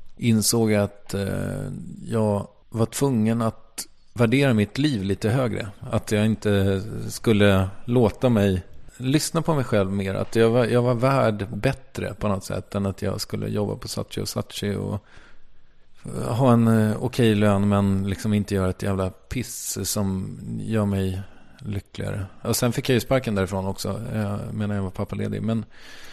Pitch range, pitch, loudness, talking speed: 100-115 Hz, 105 Hz, -24 LUFS, 165 wpm